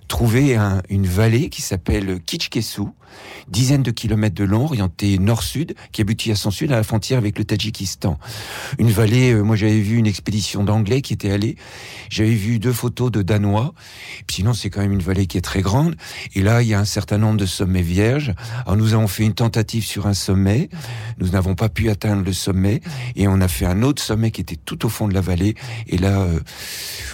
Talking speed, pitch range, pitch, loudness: 220 wpm, 100-115 Hz, 105 Hz, -19 LUFS